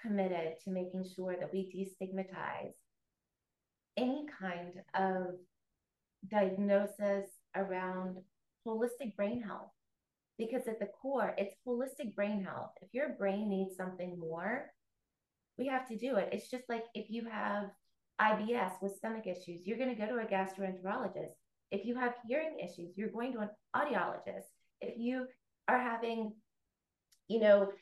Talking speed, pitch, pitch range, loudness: 145 wpm, 205 Hz, 190-235 Hz, -38 LUFS